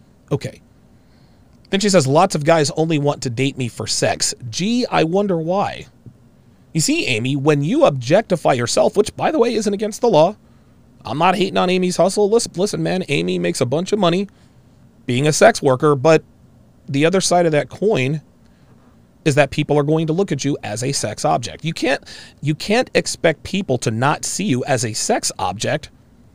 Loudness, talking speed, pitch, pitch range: -18 LUFS, 195 wpm, 150 Hz, 130-185 Hz